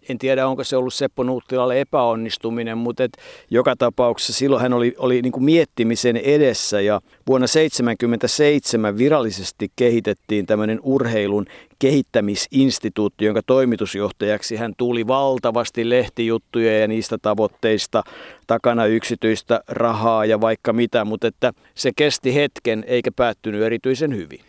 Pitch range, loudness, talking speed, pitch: 110-130 Hz, -19 LUFS, 125 wpm, 120 Hz